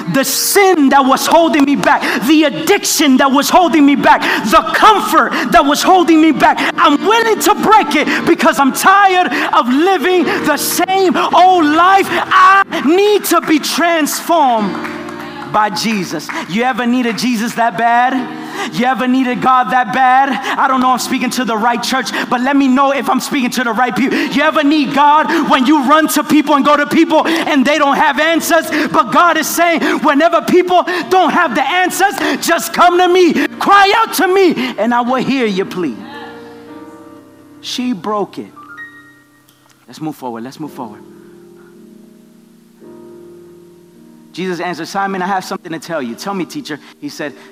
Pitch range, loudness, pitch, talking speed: 240-330 Hz, -11 LUFS, 290 Hz, 175 wpm